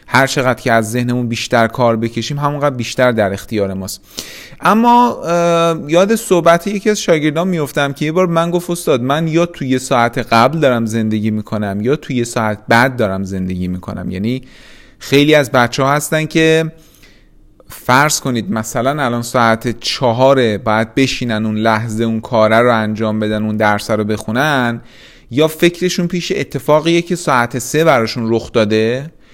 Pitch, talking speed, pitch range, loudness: 125 Hz, 155 wpm, 110-155 Hz, -14 LUFS